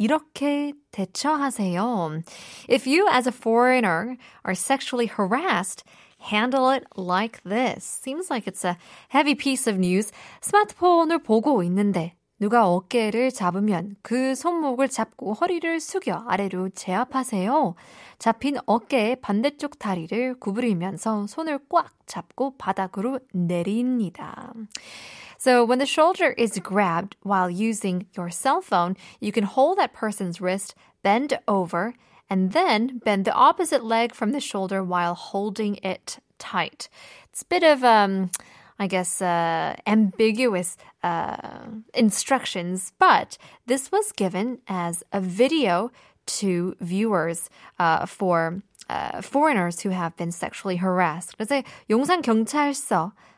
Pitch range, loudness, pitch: 190-260 Hz, -23 LUFS, 220 Hz